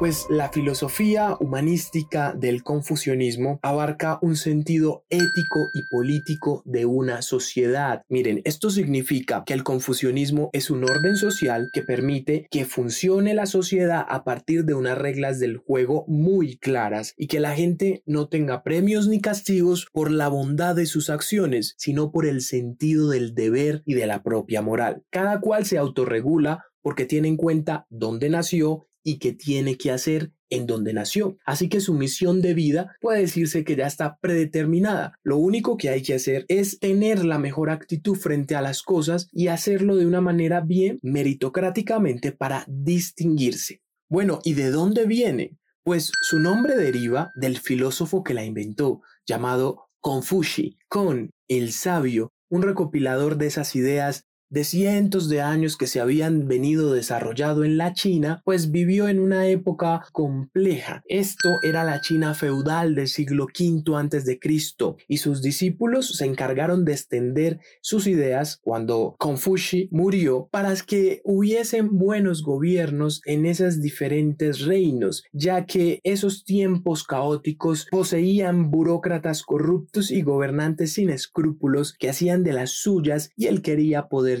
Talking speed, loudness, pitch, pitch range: 155 wpm, -23 LUFS, 155 Hz, 140-180 Hz